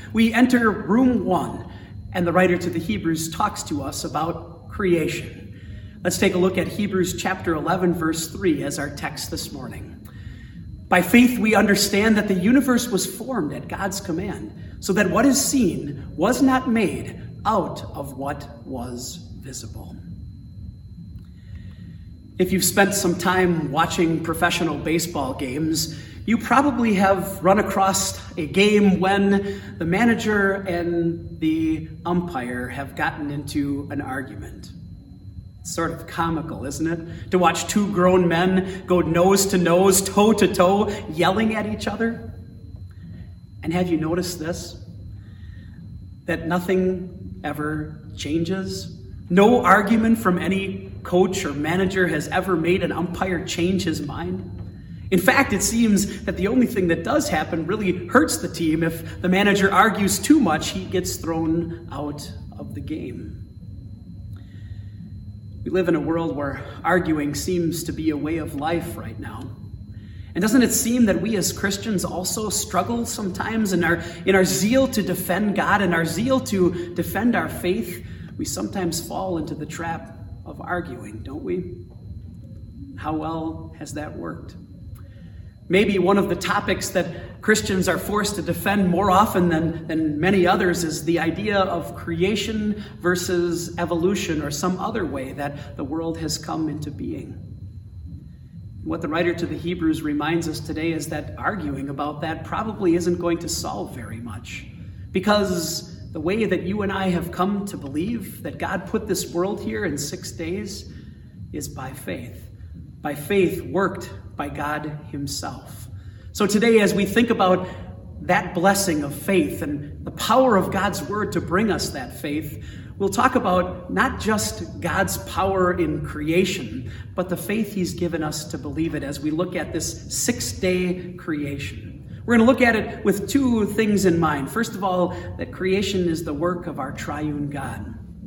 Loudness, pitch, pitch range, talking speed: -22 LUFS, 170 Hz, 130-195 Hz, 160 wpm